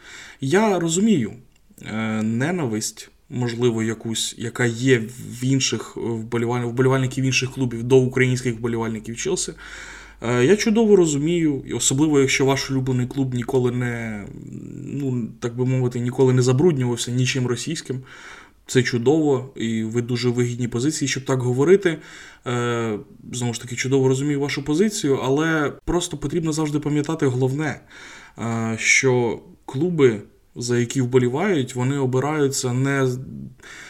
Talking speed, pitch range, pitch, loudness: 120 wpm, 120-145 Hz, 130 Hz, -21 LUFS